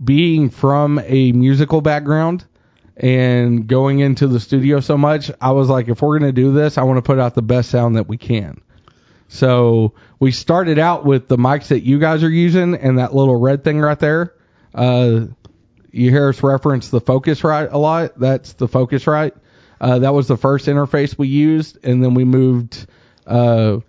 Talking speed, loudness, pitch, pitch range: 195 wpm, -15 LUFS, 135 Hz, 125-150 Hz